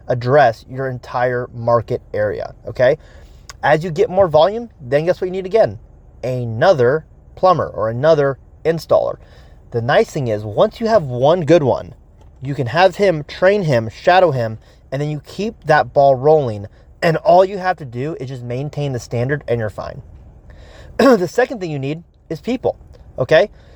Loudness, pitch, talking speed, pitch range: -17 LUFS, 145 Hz, 175 wpm, 125-185 Hz